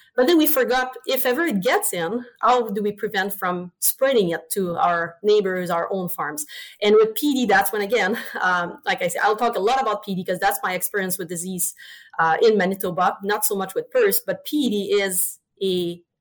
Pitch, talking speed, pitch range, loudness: 200 Hz, 205 wpm, 180-245 Hz, -21 LUFS